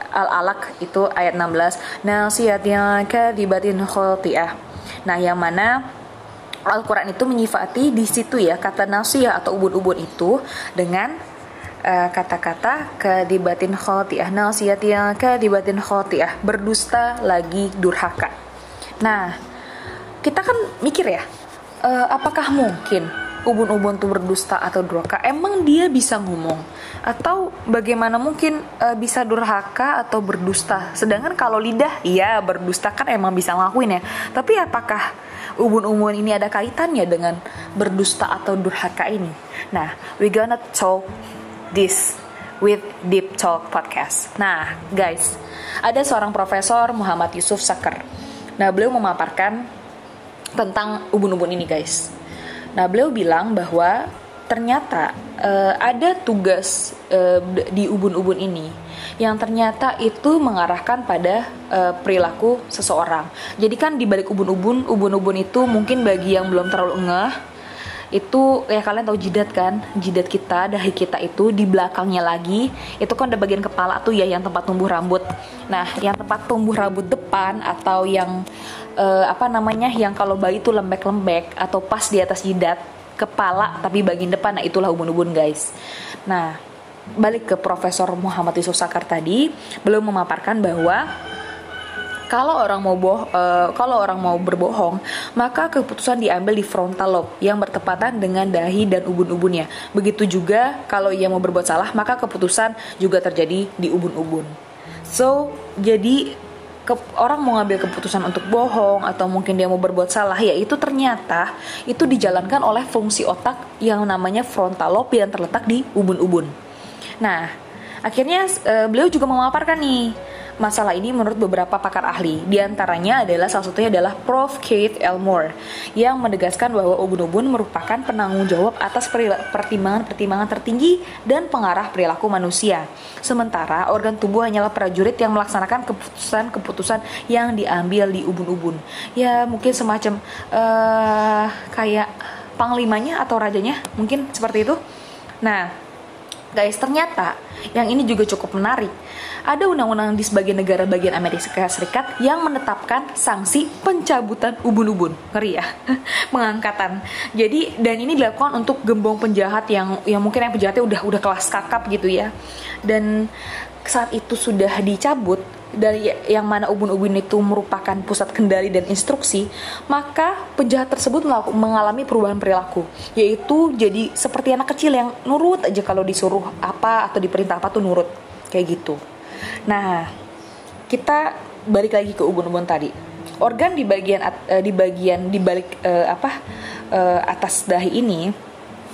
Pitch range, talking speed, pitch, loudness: 185-235 Hz, 135 wpm, 205 Hz, -19 LUFS